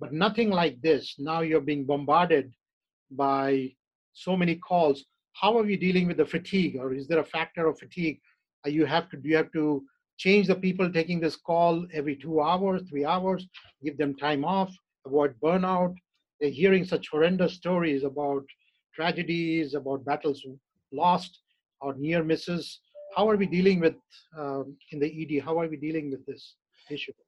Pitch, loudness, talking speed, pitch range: 160 Hz, -27 LUFS, 175 wpm, 145-180 Hz